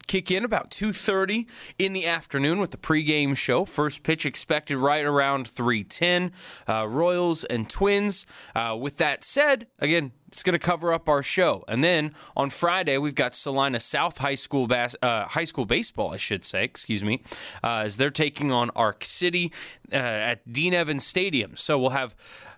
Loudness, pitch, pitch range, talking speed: -23 LUFS, 150 Hz, 135-175 Hz, 185 wpm